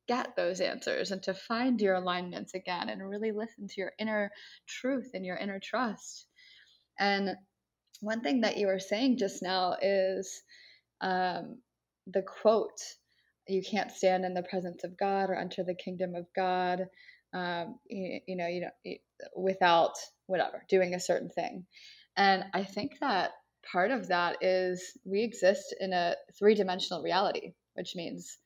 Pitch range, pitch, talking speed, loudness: 185-215 Hz, 190 Hz, 160 wpm, -32 LUFS